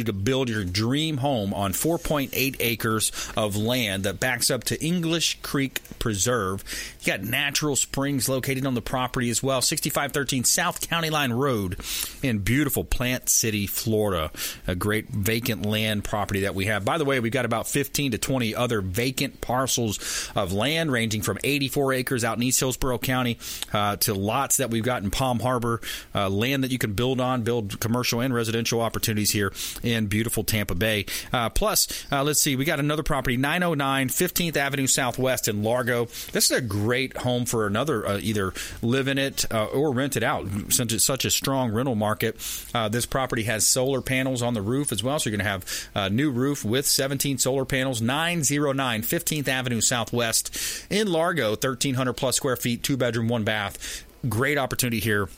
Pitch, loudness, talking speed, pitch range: 125 Hz, -24 LUFS, 190 wpm, 110-135 Hz